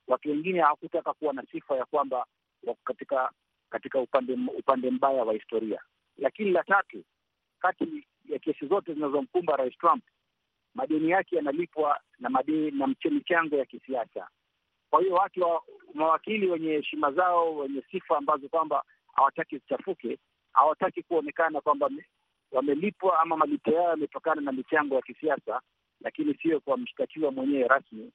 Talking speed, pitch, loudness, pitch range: 140 wpm, 160 Hz, -28 LUFS, 145-195 Hz